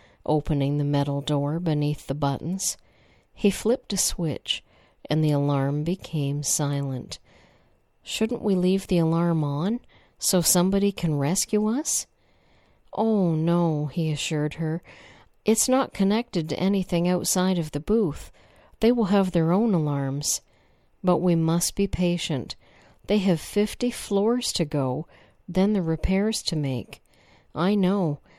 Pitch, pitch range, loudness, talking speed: 170 Hz, 150-200 Hz, -24 LUFS, 135 wpm